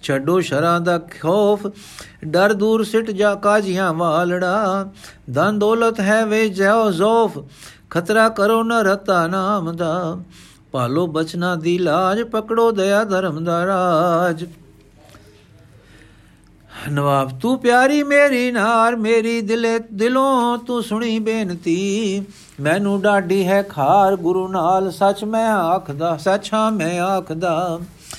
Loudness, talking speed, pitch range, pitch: -18 LUFS, 115 wpm, 170-220 Hz, 195 Hz